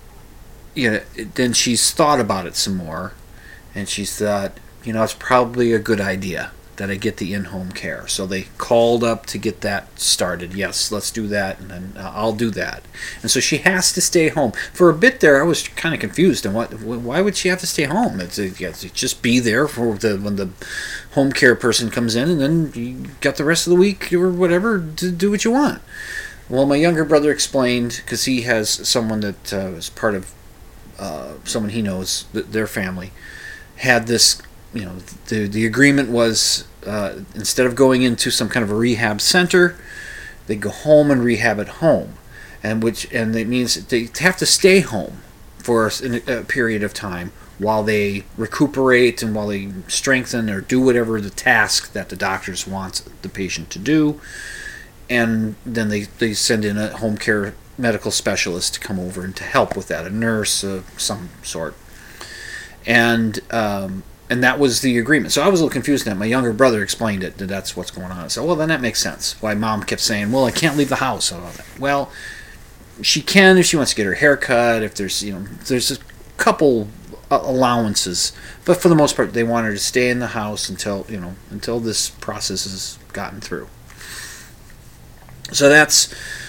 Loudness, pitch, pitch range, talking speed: -18 LUFS, 115 Hz, 100-130 Hz, 200 wpm